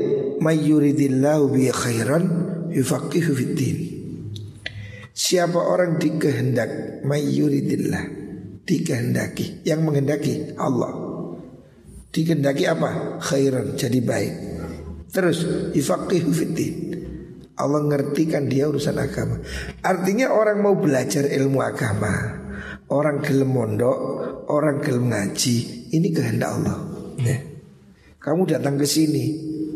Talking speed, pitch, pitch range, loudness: 85 wpm, 145 Hz, 130-165 Hz, -22 LUFS